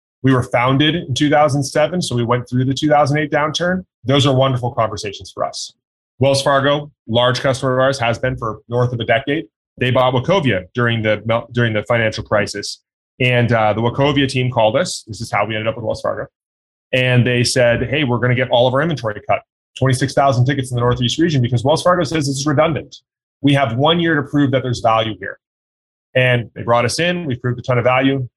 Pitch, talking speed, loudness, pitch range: 125 Hz, 220 wpm, -16 LUFS, 115-140 Hz